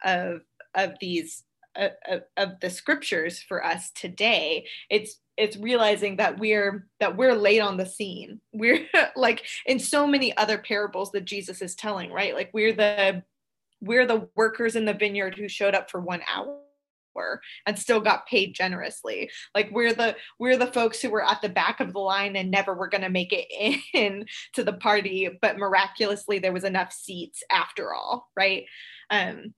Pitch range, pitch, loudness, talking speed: 195-230 Hz, 210 Hz, -25 LUFS, 180 wpm